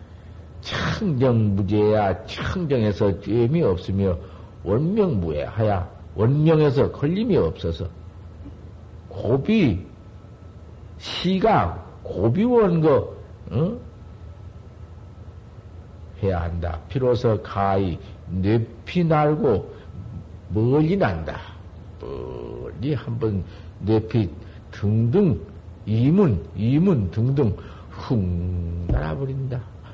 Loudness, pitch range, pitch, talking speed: -22 LUFS, 95-120 Hz, 100 Hz, 150 characters per minute